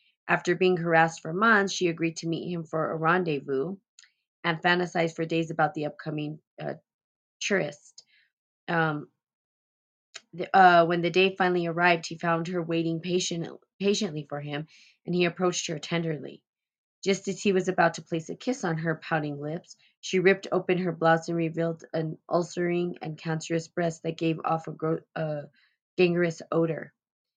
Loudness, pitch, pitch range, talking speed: -27 LUFS, 165 Hz, 160-180 Hz, 165 wpm